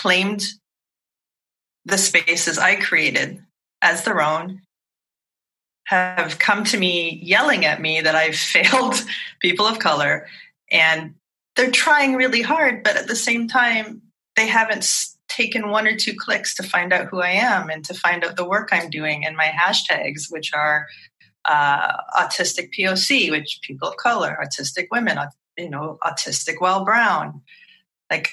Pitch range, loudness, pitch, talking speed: 160-225 Hz, -18 LUFS, 185 Hz, 155 wpm